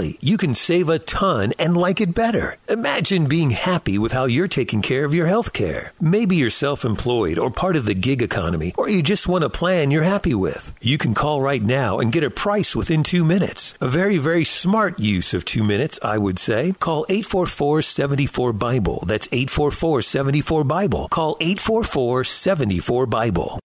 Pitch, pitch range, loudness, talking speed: 155 Hz, 125-180 Hz, -18 LUFS, 190 wpm